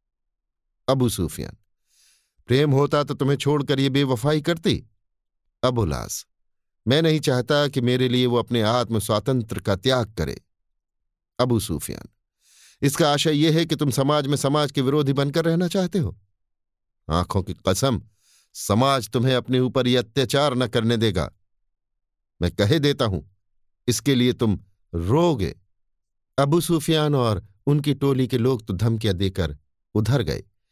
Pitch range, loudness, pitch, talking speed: 100-140 Hz, -22 LUFS, 120 Hz, 145 wpm